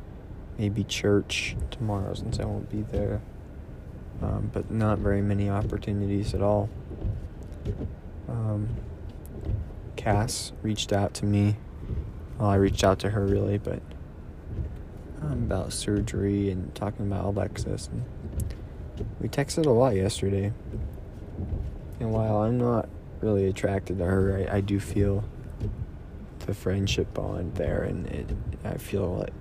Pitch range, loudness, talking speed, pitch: 95-105 Hz, -29 LUFS, 130 wpm, 100 Hz